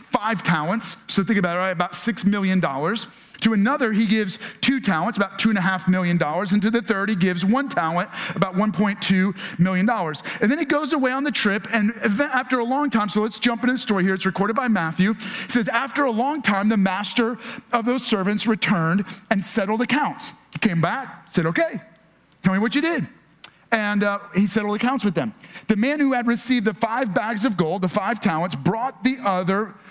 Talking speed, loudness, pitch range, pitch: 215 wpm, -21 LUFS, 190-235 Hz, 210 Hz